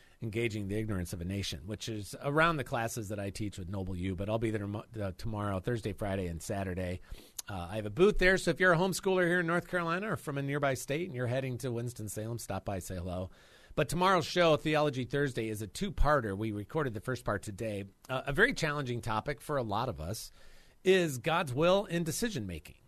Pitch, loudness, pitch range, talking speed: 115 Hz, -33 LUFS, 100-155 Hz, 220 wpm